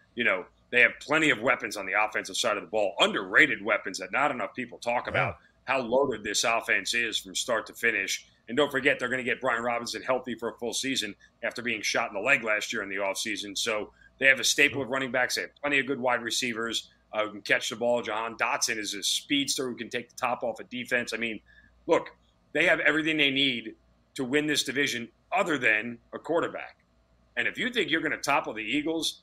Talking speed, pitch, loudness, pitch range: 240 wpm, 120 Hz, -27 LUFS, 110-135 Hz